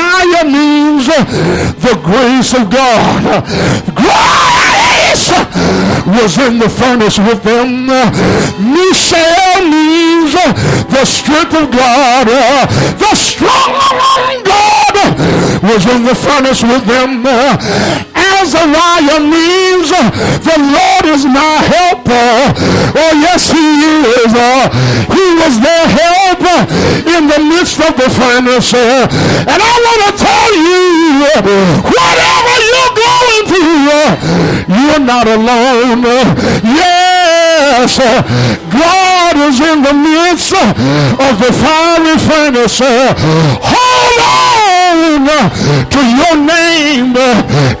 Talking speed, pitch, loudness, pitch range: 95 wpm, 300 Hz, -7 LUFS, 245-350 Hz